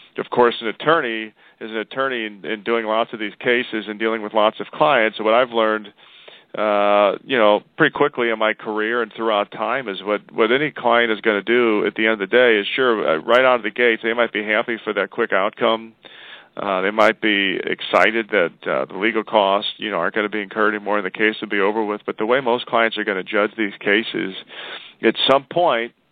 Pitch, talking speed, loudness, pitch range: 110 Hz, 240 wpm, -19 LUFS, 105-115 Hz